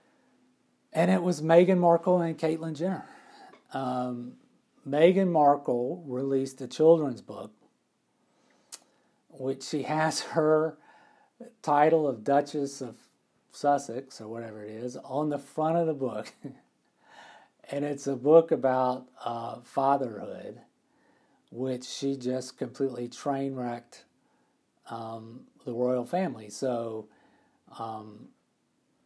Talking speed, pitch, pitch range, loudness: 110 wpm, 140 Hz, 125-160 Hz, -28 LUFS